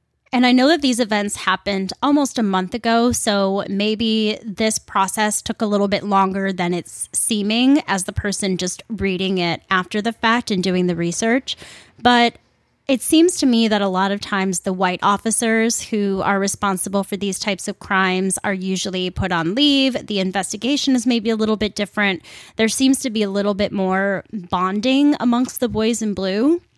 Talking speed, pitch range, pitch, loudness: 190 wpm, 195-230 Hz, 205 Hz, -19 LUFS